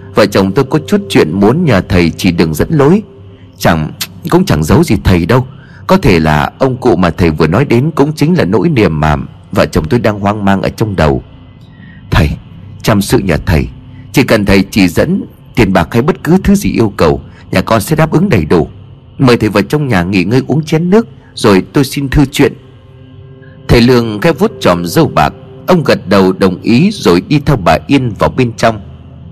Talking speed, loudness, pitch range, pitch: 215 wpm, -10 LUFS, 95-140 Hz, 115 Hz